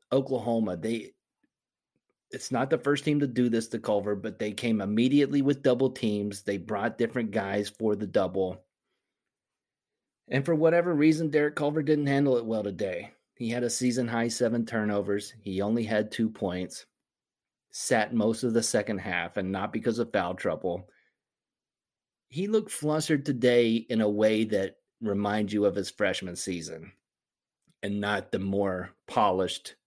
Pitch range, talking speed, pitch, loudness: 100-130 Hz, 160 wpm, 115 Hz, -28 LUFS